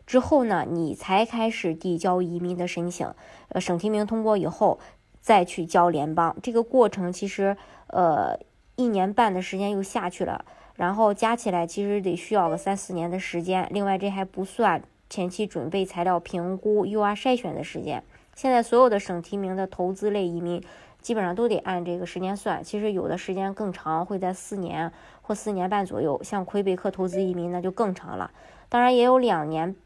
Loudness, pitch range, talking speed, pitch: -25 LUFS, 175-210 Hz, 290 characters per minute, 190 Hz